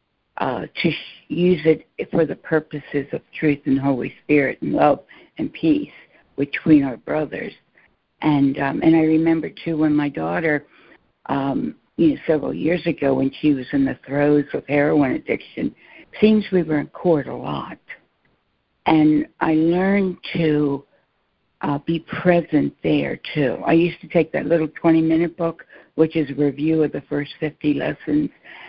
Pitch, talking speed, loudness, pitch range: 155 Hz, 160 wpm, -20 LUFS, 145-165 Hz